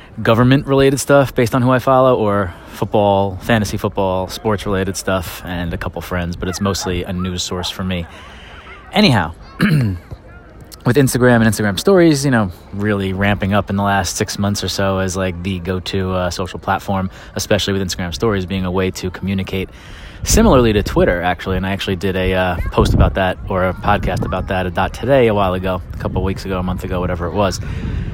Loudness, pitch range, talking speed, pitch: -17 LUFS, 90-105 Hz, 200 wpm, 95 Hz